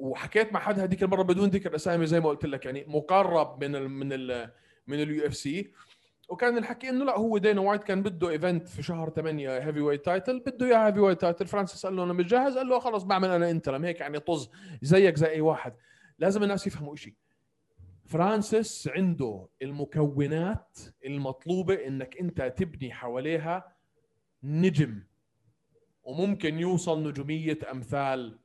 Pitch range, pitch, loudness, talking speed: 140-190 Hz, 160 Hz, -28 LUFS, 160 wpm